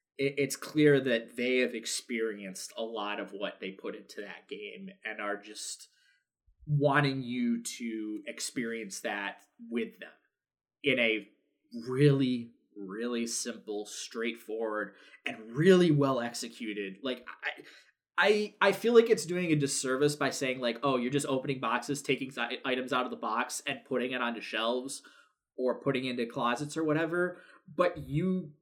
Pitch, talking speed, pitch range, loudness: 125 Hz, 150 wpm, 115-145 Hz, -31 LUFS